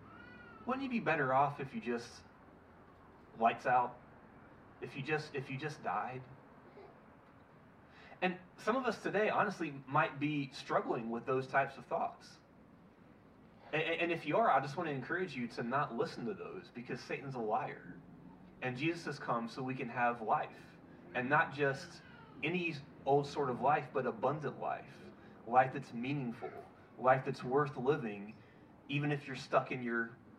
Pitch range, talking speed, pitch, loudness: 125-150 Hz, 165 wpm, 135 Hz, -36 LUFS